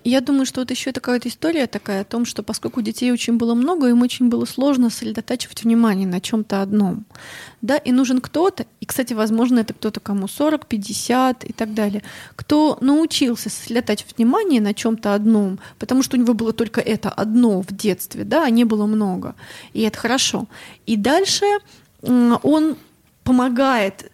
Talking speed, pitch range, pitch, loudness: 170 wpm, 215-260 Hz, 235 Hz, -19 LUFS